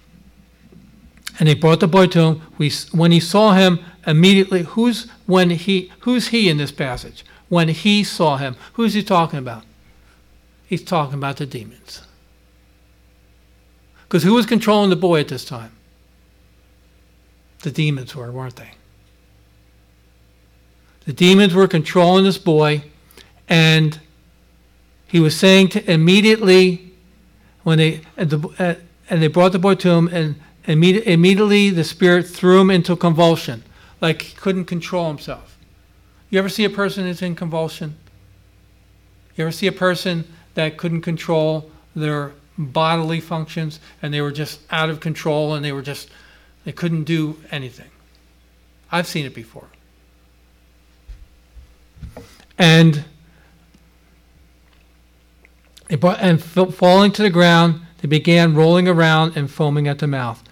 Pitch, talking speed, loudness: 155 Hz, 135 wpm, -16 LUFS